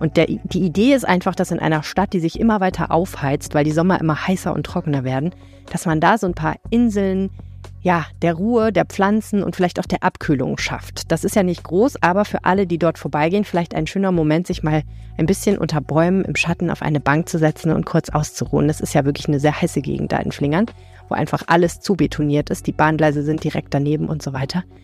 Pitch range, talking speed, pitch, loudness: 150-185 Hz, 235 wpm, 165 Hz, -19 LUFS